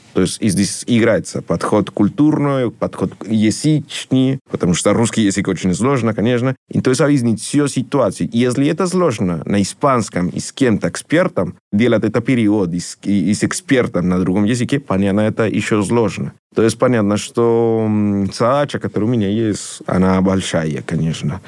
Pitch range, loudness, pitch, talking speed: 100-125 Hz, -16 LUFS, 110 Hz, 160 wpm